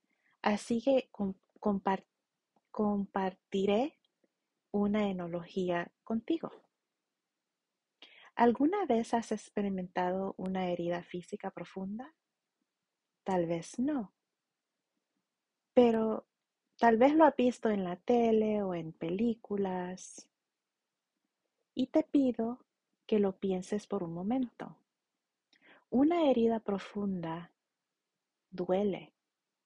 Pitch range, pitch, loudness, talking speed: 185-240 Hz, 205 Hz, -32 LUFS, 85 wpm